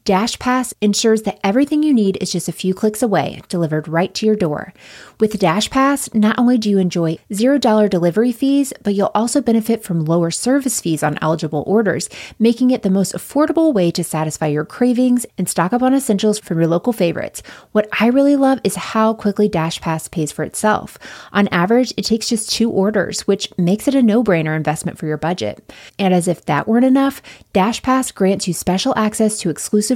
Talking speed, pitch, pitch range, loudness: 205 wpm, 210 Hz, 175-235 Hz, -17 LUFS